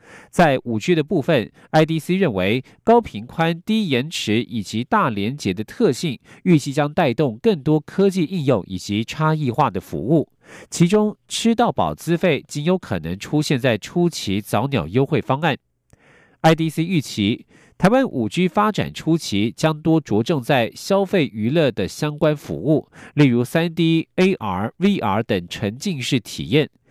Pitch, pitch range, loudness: 155 Hz, 120-175 Hz, -20 LUFS